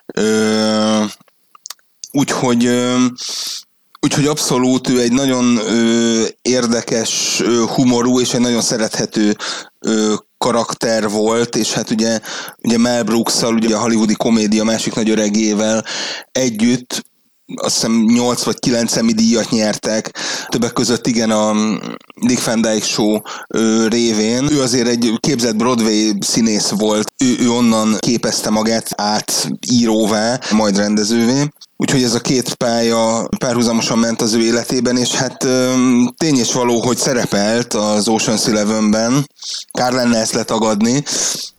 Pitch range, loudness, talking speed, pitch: 110-125 Hz, -15 LUFS, 130 wpm, 115 Hz